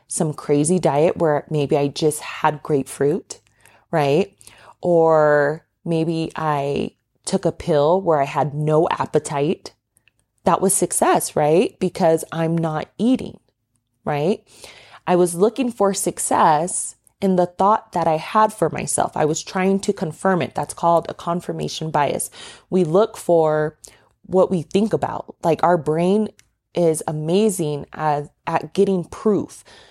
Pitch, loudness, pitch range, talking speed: 165 Hz, -20 LUFS, 150-190 Hz, 140 wpm